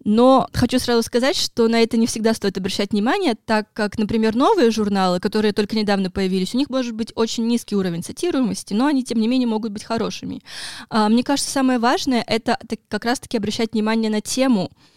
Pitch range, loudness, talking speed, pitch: 215-245 Hz, -20 LUFS, 190 wpm, 225 Hz